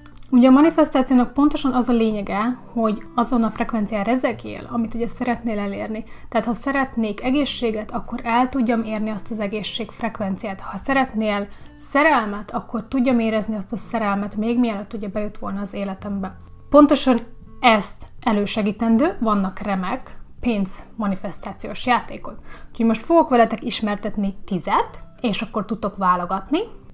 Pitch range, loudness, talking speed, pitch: 205-245 Hz, -21 LUFS, 140 wpm, 225 Hz